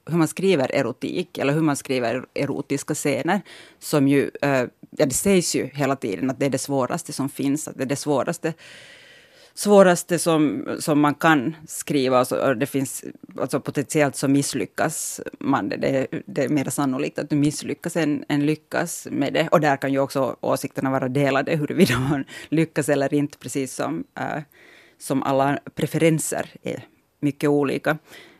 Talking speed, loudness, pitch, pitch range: 170 wpm, -22 LUFS, 145 Hz, 135-155 Hz